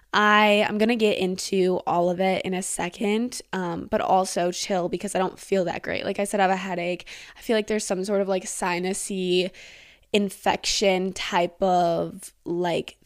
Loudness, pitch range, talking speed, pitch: -24 LUFS, 180-205 Hz, 190 wpm, 190 Hz